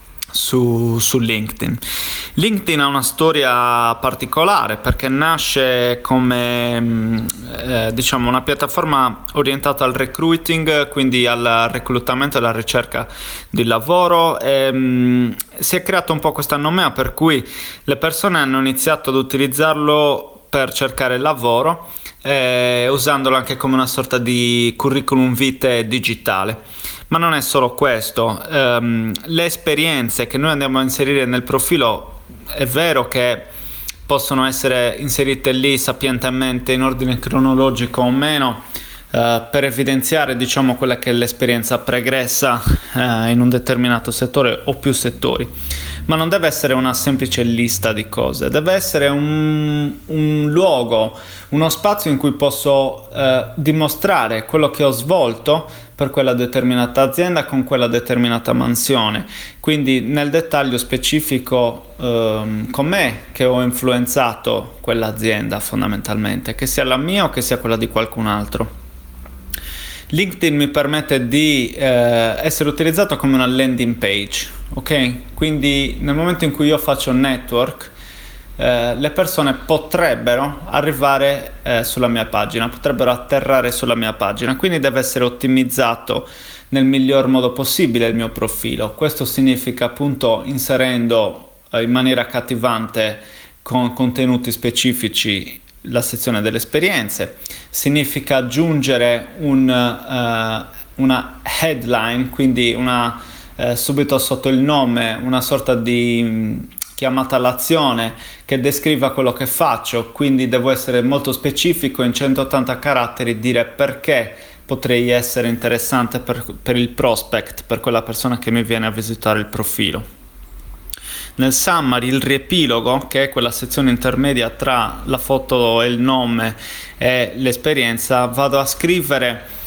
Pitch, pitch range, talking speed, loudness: 130 Hz, 120-140 Hz, 135 wpm, -16 LUFS